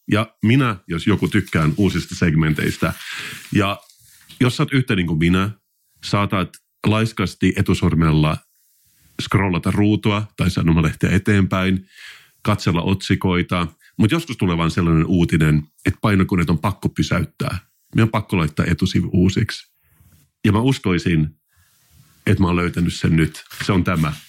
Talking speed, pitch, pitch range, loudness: 135 wpm, 95 Hz, 85-105 Hz, -19 LUFS